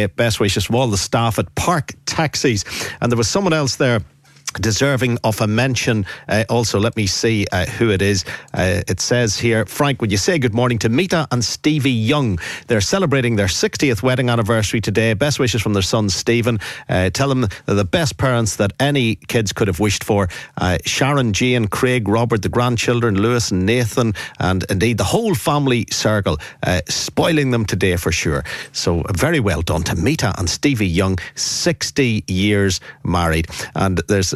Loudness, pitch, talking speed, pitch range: -18 LUFS, 115 Hz, 185 wpm, 100-125 Hz